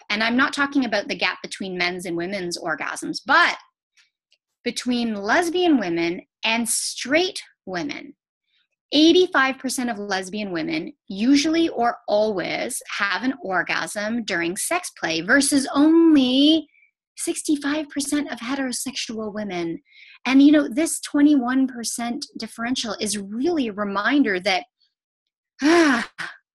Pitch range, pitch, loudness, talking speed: 215-300 Hz, 265 Hz, -21 LUFS, 115 wpm